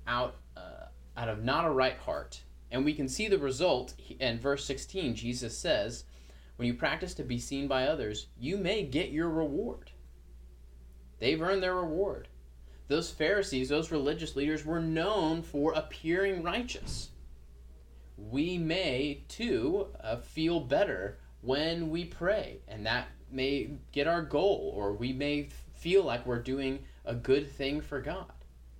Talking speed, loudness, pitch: 155 wpm, -32 LUFS, 140 Hz